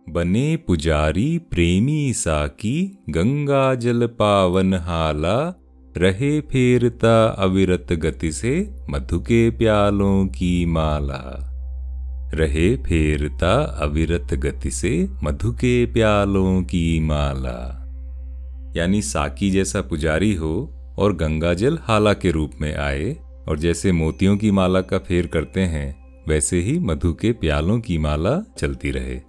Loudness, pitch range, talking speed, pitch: -20 LUFS, 75-105 Hz, 115 wpm, 85 Hz